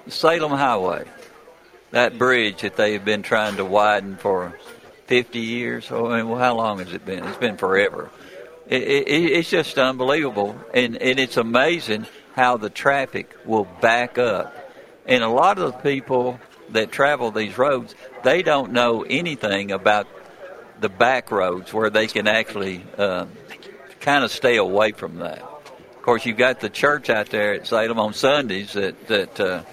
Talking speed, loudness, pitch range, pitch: 170 wpm, -20 LUFS, 105-130 Hz, 115 Hz